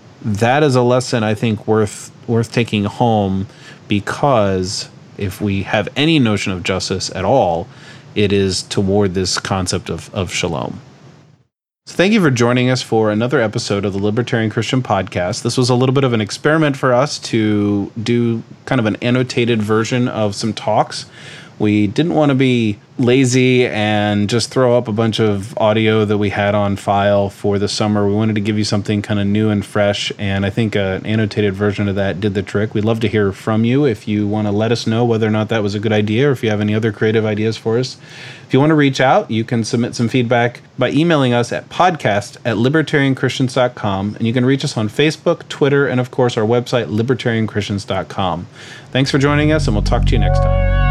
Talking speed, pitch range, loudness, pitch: 210 wpm, 105-130 Hz, -16 LUFS, 115 Hz